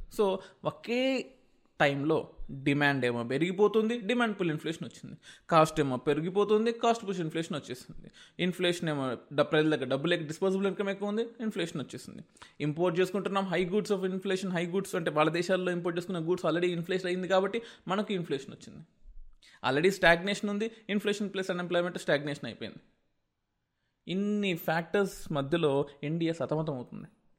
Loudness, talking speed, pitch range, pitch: -30 LUFS, 140 wpm, 155-200 Hz, 180 Hz